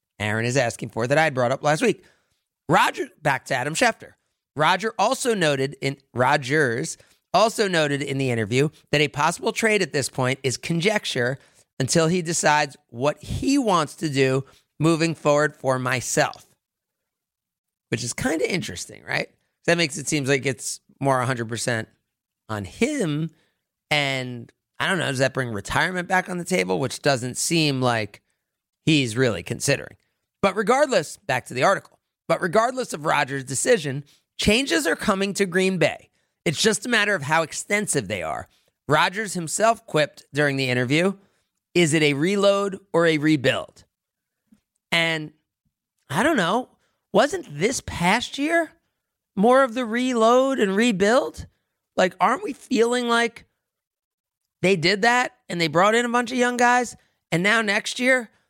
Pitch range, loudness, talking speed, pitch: 135-215 Hz, -22 LUFS, 160 wpm, 165 Hz